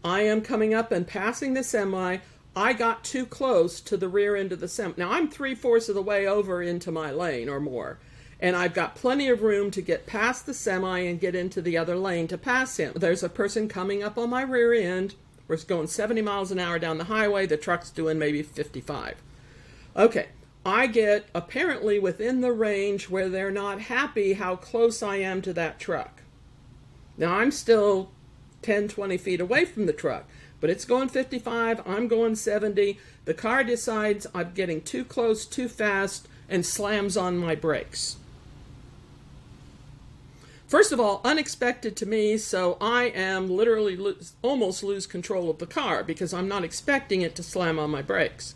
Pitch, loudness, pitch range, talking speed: 200 Hz, -26 LUFS, 180-230 Hz, 185 wpm